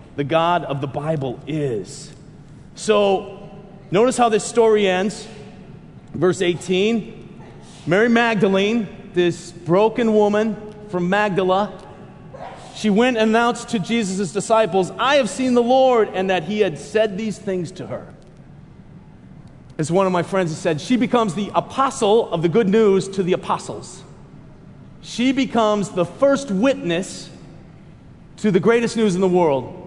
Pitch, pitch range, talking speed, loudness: 195 Hz, 175-220 Hz, 145 wpm, -19 LUFS